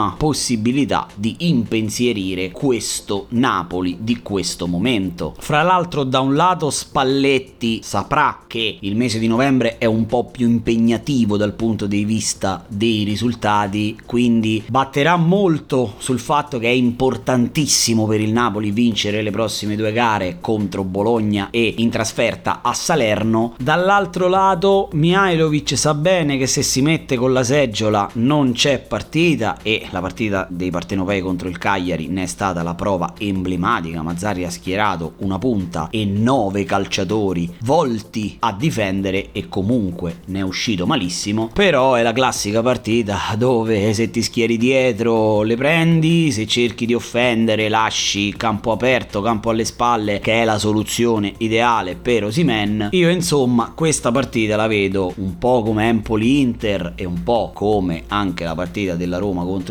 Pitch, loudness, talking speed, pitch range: 110 Hz, -18 LUFS, 150 wpm, 100-125 Hz